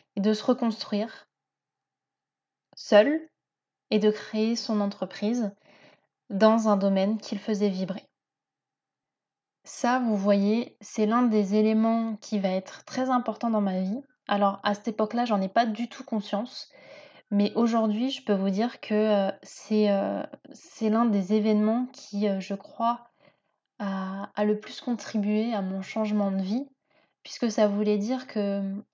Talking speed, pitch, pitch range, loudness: 150 wpm, 215 Hz, 205-235 Hz, -27 LUFS